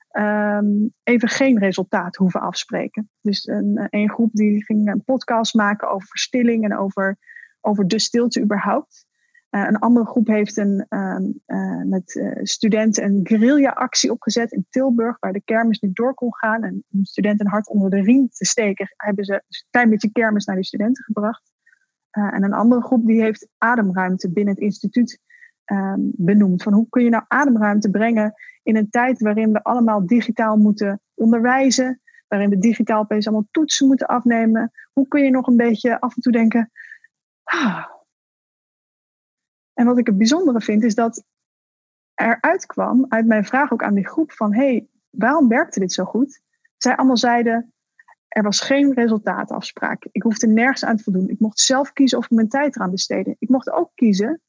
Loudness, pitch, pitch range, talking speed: -18 LUFS, 225 Hz, 210-255 Hz, 185 wpm